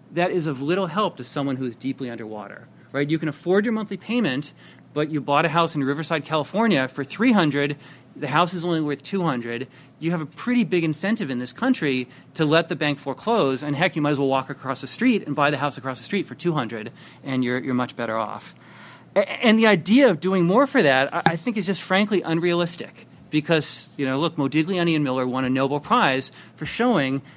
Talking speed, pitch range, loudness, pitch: 230 wpm, 135-180 Hz, -22 LUFS, 150 Hz